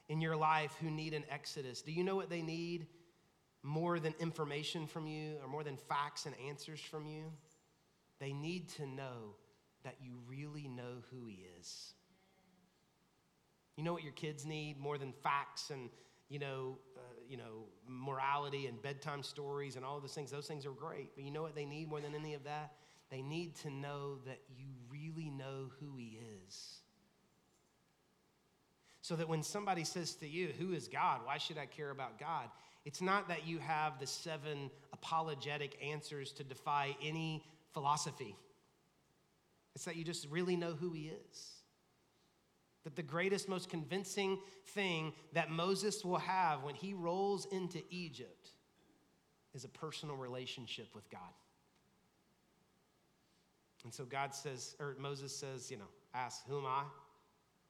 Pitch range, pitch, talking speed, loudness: 140-165 Hz, 150 Hz, 165 wpm, -43 LUFS